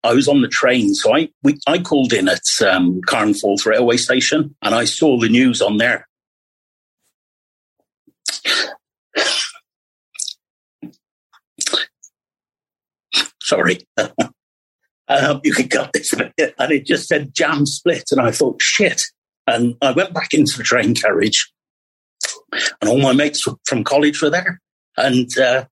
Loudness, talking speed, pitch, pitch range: -16 LUFS, 140 wpm, 135 Hz, 110-170 Hz